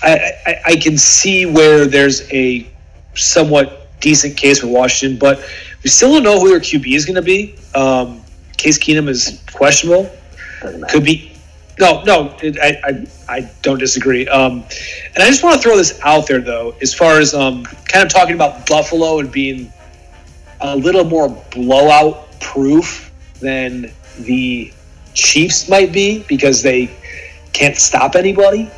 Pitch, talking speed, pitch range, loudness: 140 Hz, 160 wpm, 125-160 Hz, -11 LUFS